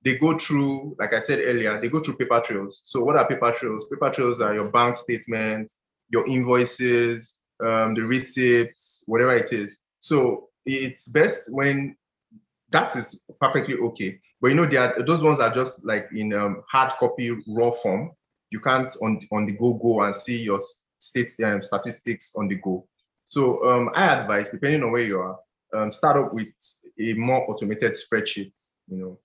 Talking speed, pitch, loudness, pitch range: 185 wpm, 120 Hz, -23 LUFS, 110-130 Hz